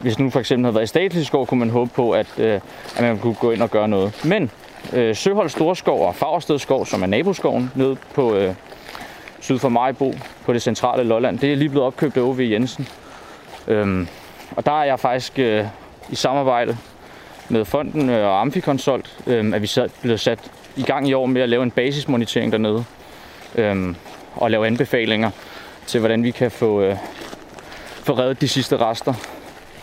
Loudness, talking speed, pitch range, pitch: -20 LUFS, 175 wpm, 110-135 Hz, 120 Hz